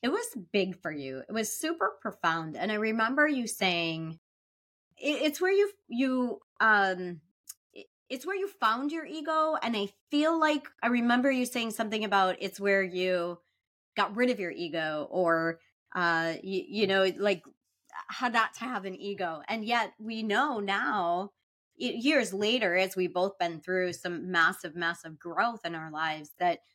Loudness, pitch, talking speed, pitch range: -29 LUFS, 200 Hz, 170 wpm, 175-245 Hz